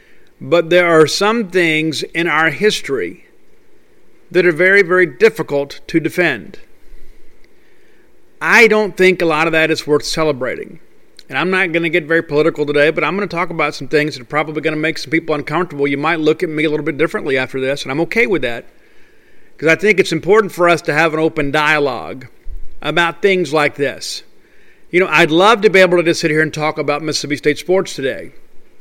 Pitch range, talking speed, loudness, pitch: 155-200 Hz, 210 wpm, -14 LUFS, 165 Hz